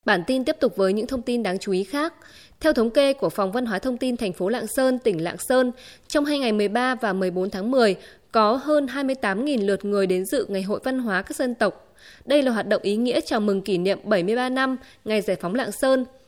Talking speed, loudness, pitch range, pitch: 245 wpm, -23 LUFS, 200-265 Hz, 240 Hz